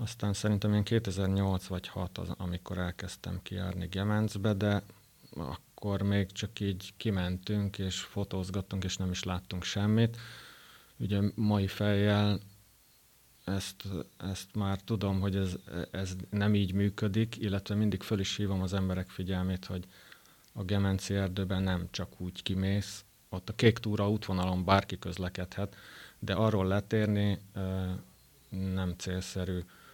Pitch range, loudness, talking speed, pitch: 95-105 Hz, -33 LUFS, 130 wpm, 95 Hz